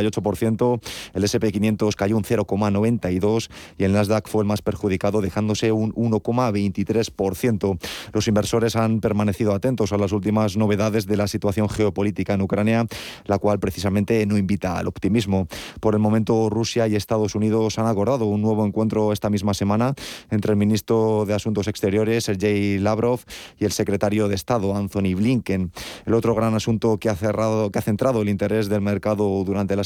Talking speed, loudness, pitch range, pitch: 170 wpm, -22 LUFS, 100-110 Hz, 105 Hz